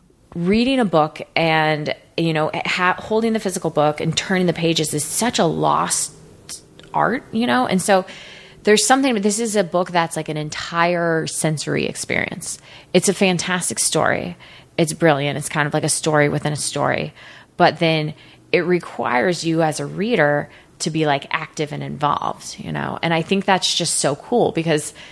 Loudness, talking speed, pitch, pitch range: -19 LUFS, 180 wpm, 165 Hz, 155-185 Hz